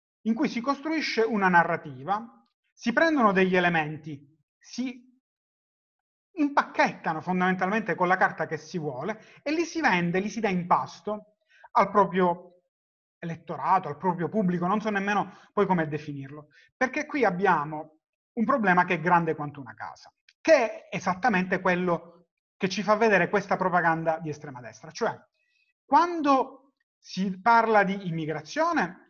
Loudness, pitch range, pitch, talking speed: -26 LUFS, 170-245 Hz, 195 Hz, 145 wpm